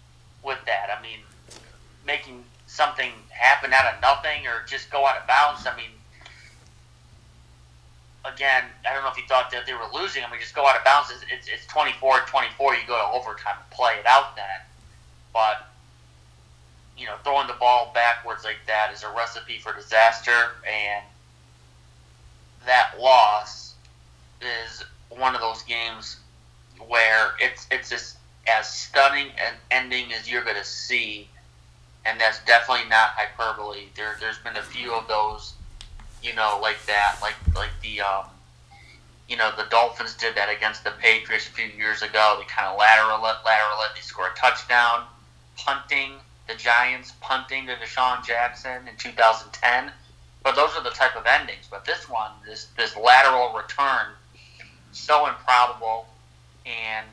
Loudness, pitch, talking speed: -22 LUFS, 110 Hz, 160 wpm